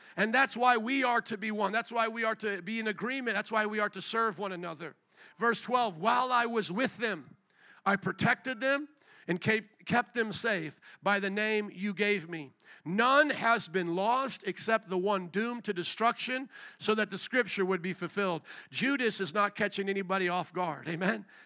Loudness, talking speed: -31 LUFS, 195 wpm